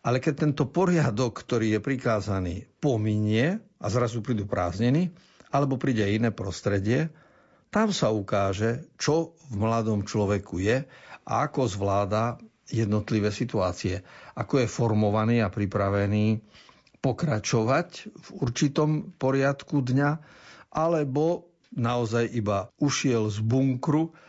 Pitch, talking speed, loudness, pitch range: 120 Hz, 115 wpm, -26 LUFS, 105-150 Hz